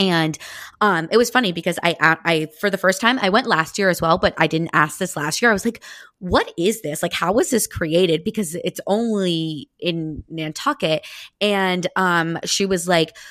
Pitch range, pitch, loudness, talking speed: 160-200 Hz, 180 Hz, -19 LUFS, 210 wpm